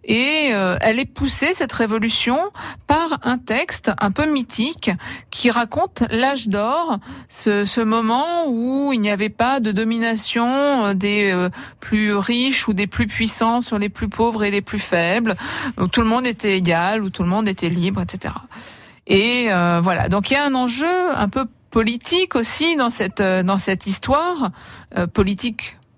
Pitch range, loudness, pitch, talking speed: 205-260 Hz, -19 LUFS, 225 Hz, 180 wpm